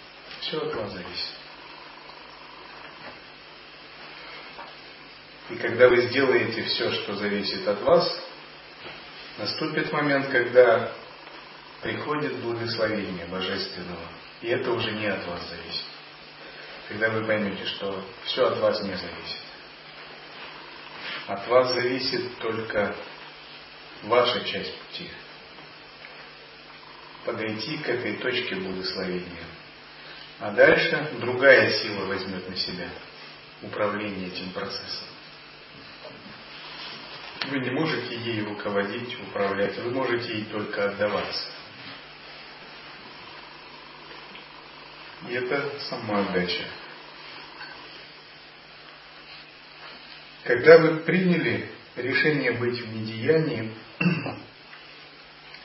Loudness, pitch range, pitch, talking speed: -25 LUFS, 100-125 Hz, 110 Hz, 85 wpm